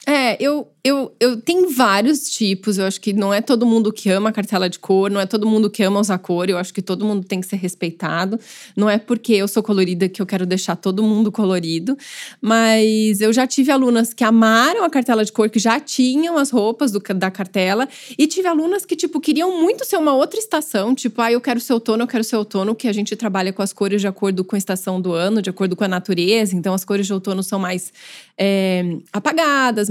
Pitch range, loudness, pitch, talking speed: 195-250 Hz, -18 LUFS, 215 Hz, 235 wpm